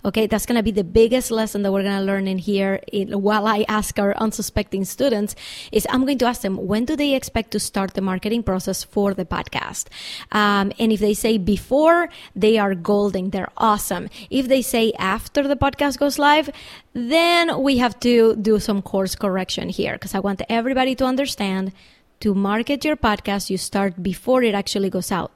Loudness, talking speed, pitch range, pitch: -20 LUFS, 195 wpm, 195-245 Hz, 210 Hz